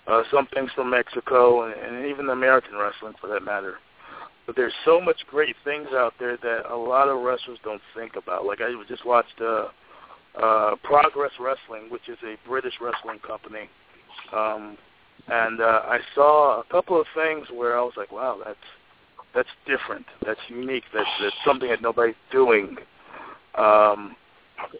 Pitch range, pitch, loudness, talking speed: 115-145 Hz, 125 Hz, -23 LUFS, 165 wpm